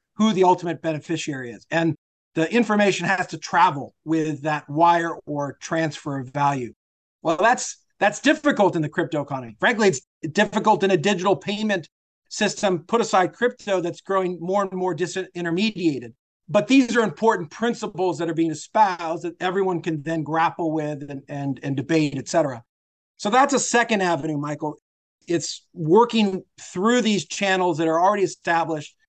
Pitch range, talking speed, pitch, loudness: 155-205 Hz, 165 wpm, 175 Hz, -22 LUFS